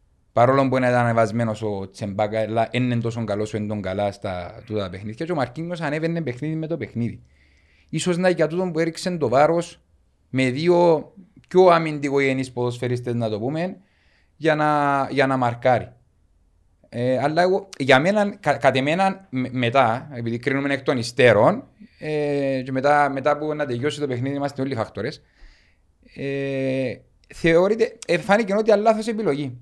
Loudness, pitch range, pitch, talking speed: -21 LUFS, 115-160 Hz, 135 Hz, 165 wpm